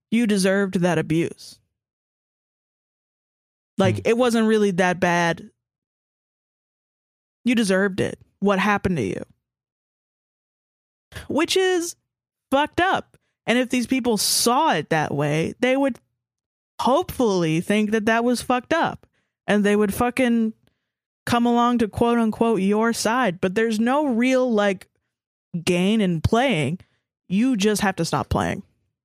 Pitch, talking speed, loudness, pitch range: 215 Hz, 130 wpm, -21 LUFS, 185-245 Hz